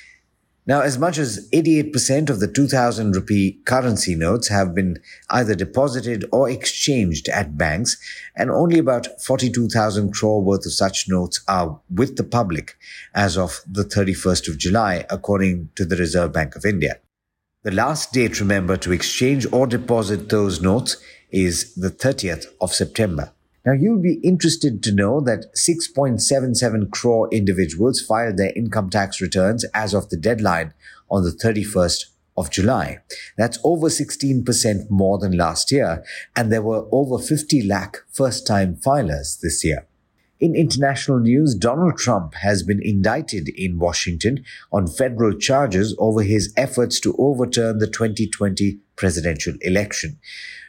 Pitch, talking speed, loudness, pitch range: 110 Hz, 145 wpm, -20 LUFS, 95-130 Hz